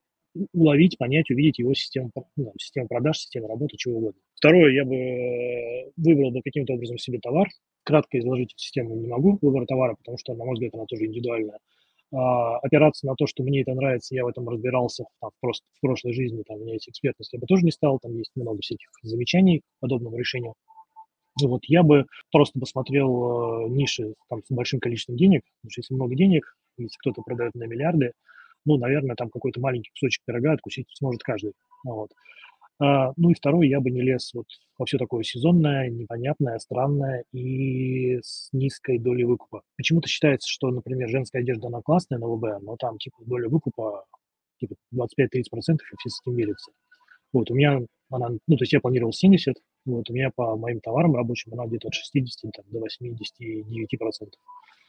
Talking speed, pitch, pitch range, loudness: 185 wpm, 130 Hz, 120-145 Hz, -24 LUFS